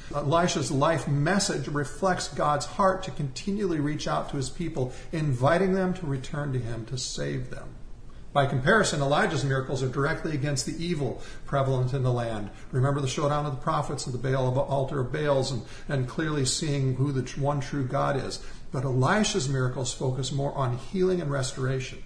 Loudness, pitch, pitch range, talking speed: -27 LUFS, 140 Hz, 130-160 Hz, 185 wpm